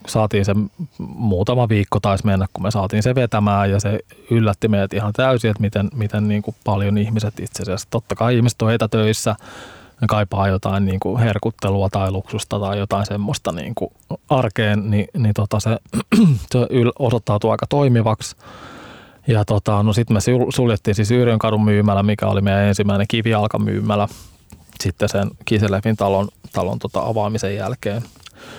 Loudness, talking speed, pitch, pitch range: -19 LUFS, 155 wpm, 105 Hz, 100-115 Hz